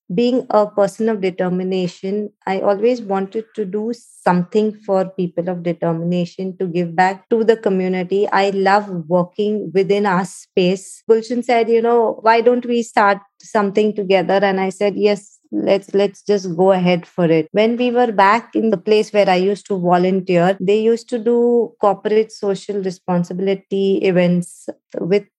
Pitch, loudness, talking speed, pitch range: 200 Hz, -17 LUFS, 165 wpm, 185-215 Hz